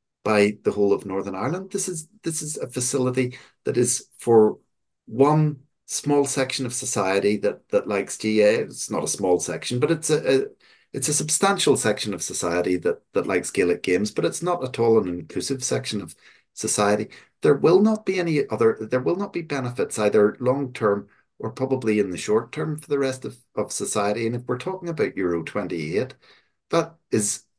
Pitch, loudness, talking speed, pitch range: 125 Hz, -23 LUFS, 195 wpm, 105-150 Hz